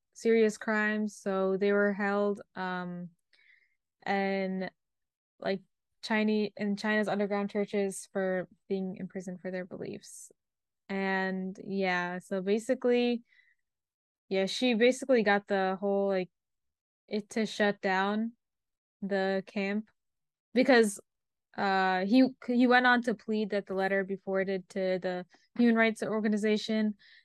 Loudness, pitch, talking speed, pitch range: -30 LUFS, 200 Hz, 120 wpm, 190-215 Hz